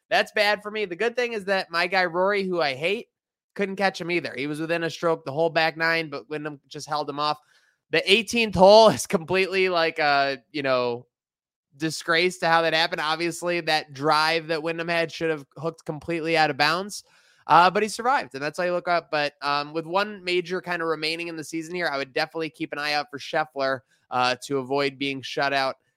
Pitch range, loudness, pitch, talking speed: 145-180 Hz, -24 LUFS, 165 Hz, 225 wpm